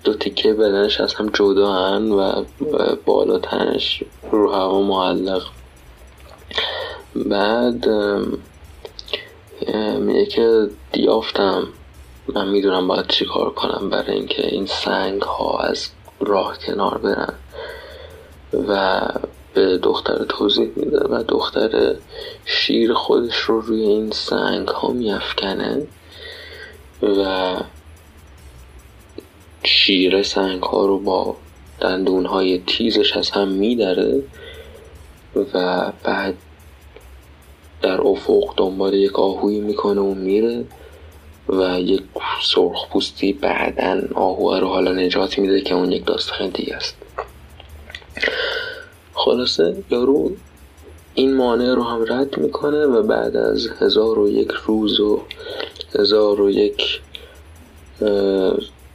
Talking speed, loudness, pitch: 105 wpm, -19 LUFS, 100 Hz